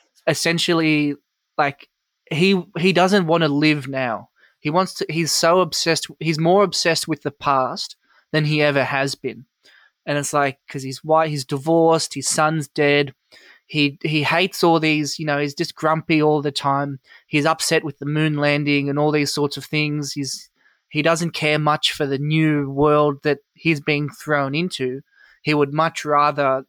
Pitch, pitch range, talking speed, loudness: 150 Hz, 145-165 Hz, 180 wpm, -19 LUFS